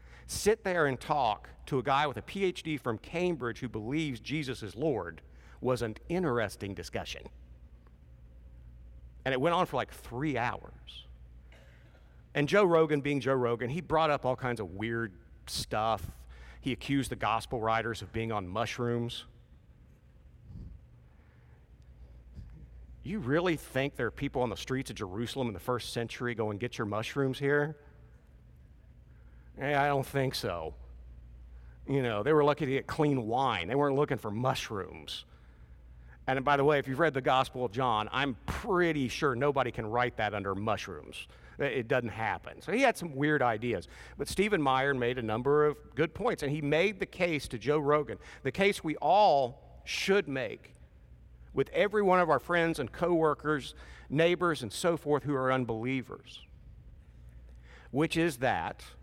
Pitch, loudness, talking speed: 120 Hz, -31 LUFS, 165 wpm